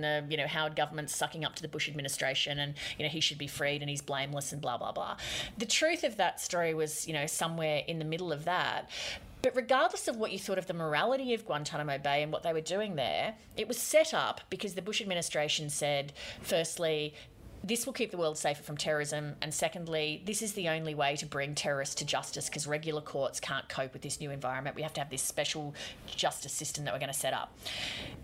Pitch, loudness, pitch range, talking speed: 150 Hz, -33 LUFS, 145-175 Hz, 235 wpm